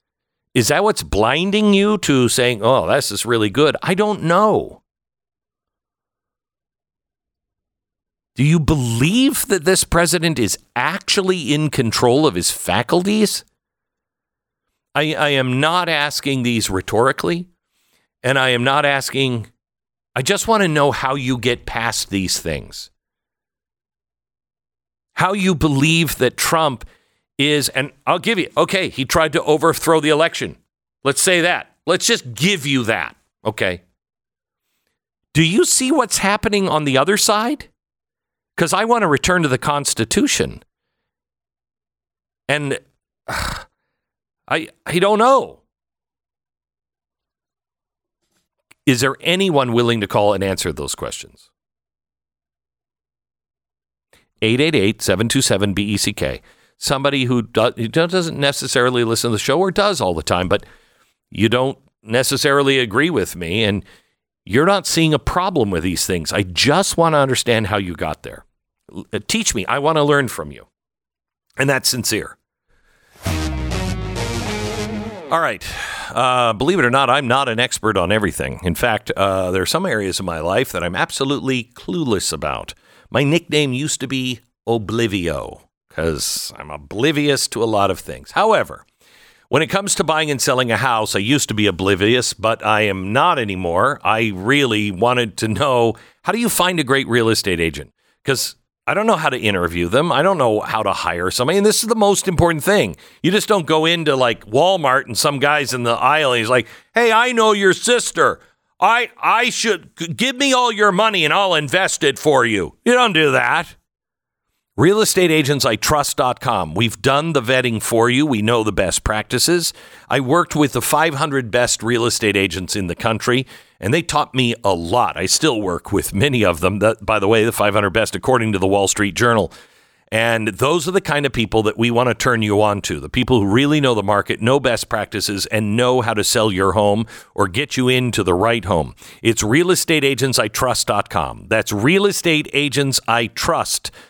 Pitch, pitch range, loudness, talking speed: 125 Hz, 105-160 Hz, -17 LUFS, 165 wpm